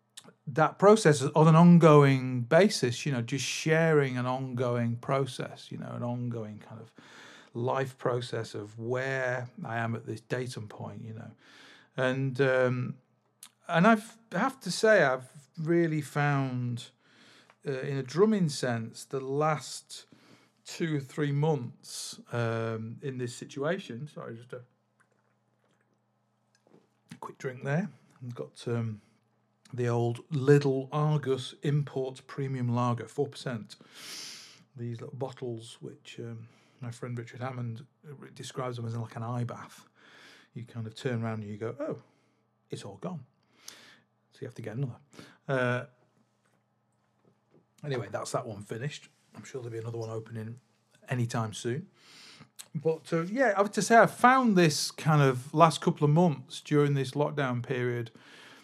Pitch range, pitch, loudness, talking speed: 115-145 Hz, 130 Hz, -29 LUFS, 145 wpm